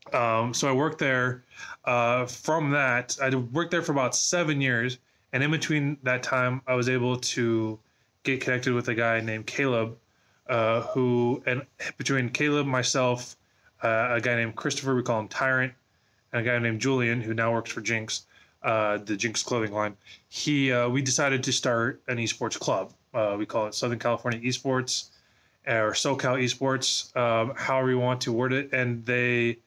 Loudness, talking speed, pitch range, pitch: -26 LUFS, 180 wpm, 115-130 Hz, 125 Hz